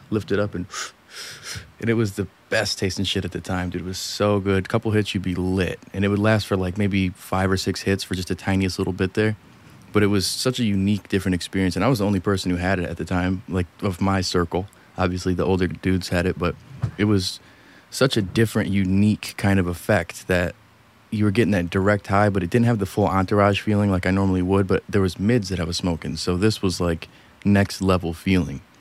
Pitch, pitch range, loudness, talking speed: 95 Hz, 90-105 Hz, -22 LUFS, 245 wpm